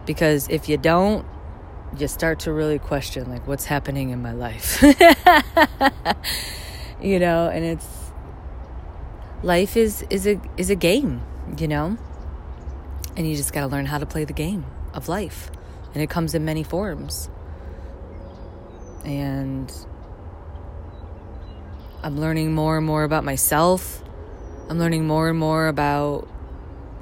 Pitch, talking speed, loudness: 140 Hz, 135 wpm, -21 LUFS